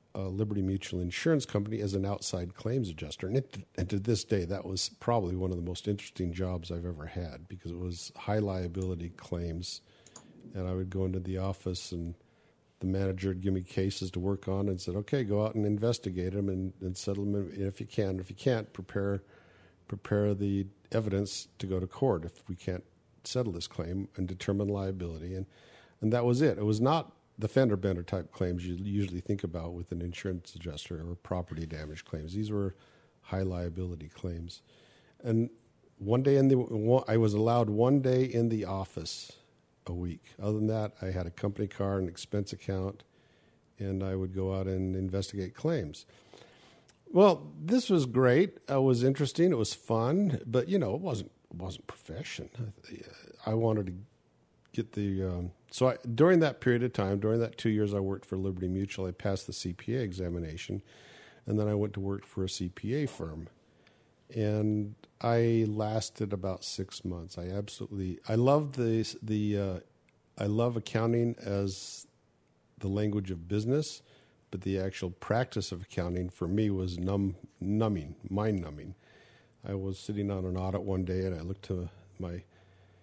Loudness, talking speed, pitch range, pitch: -32 LUFS, 180 wpm, 90-110 Hz, 100 Hz